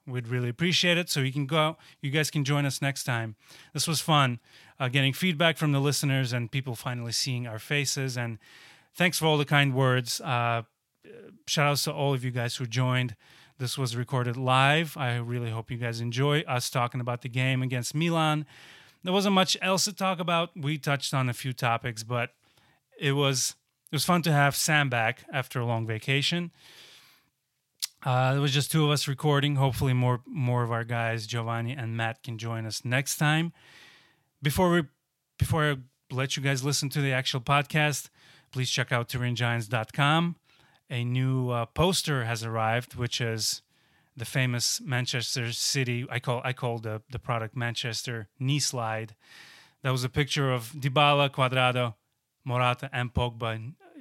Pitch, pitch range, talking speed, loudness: 130 Hz, 120-145 Hz, 180 wpm, -27 LUFS